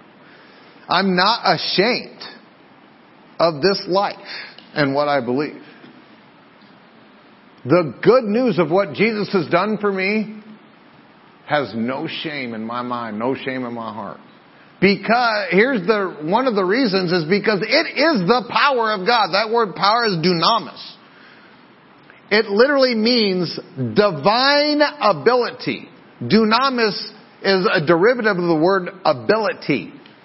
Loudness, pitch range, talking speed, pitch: -18 LUFS, 170-225 Hz, 125 wpm, 200 Hz